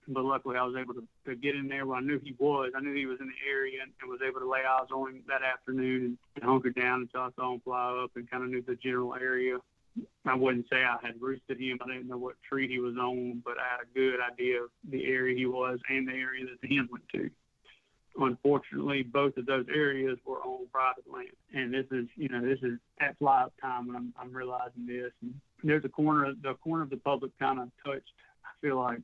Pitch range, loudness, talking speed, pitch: 125-135 Hz, -32 LUFS, 250 wpm, 130 Hz